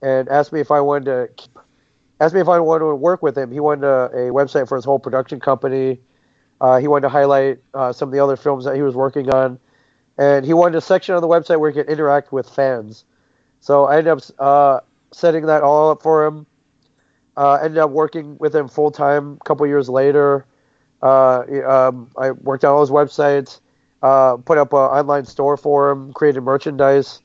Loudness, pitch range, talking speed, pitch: -16 LUFS, 135-150 Hz, 215 wpm, 140 Hz